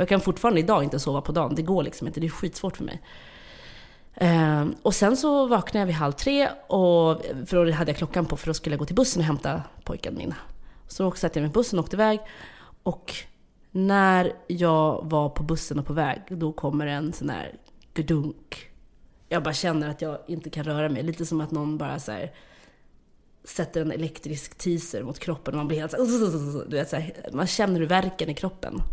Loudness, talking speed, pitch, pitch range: -26 LUFS, 215 wpm, 160 Hz, 150-185 Hz